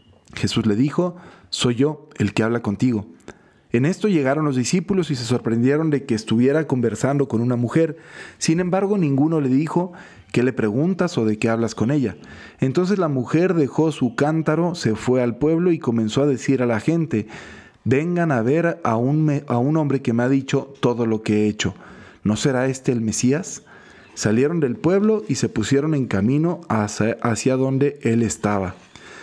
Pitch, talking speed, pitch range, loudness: 135 Hz, 185 wpm, 115-155 Hz, -20 LUFS